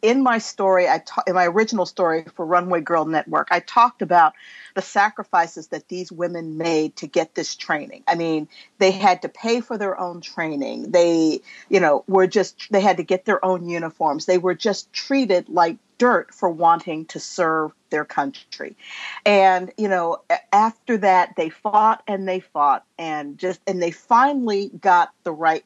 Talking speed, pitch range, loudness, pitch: 180 wpm, 170-210 Hz, -20 LUFS, 185 Hz